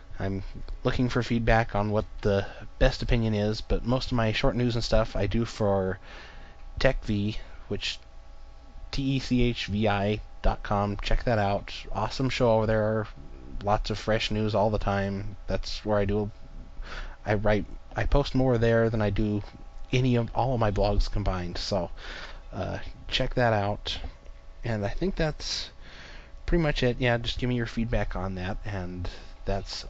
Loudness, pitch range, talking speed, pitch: -28 LUFS, 95-115 Hz, 165 wpm, 105 Hz